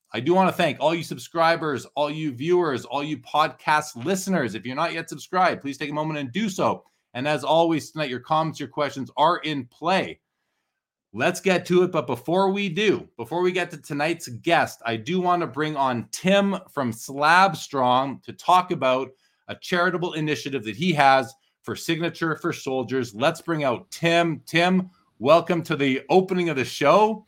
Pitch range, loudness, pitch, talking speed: 135-175 Hz, -23 LUFS, 155 Hz, 190 wpm